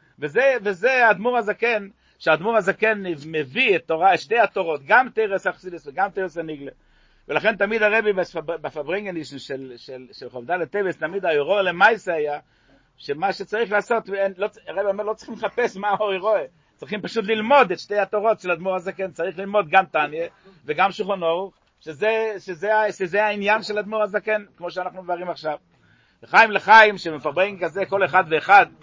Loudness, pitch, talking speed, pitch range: -21 LUFS, 195 Hz, 155 wpm, 170-215 Hz